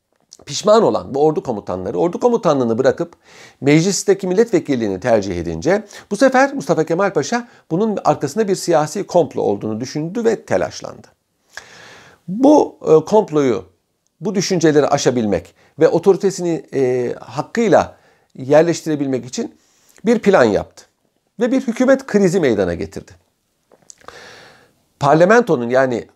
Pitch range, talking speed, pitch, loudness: 130-205 Hz, 110 wpm, 165 Hz, -16 LUFS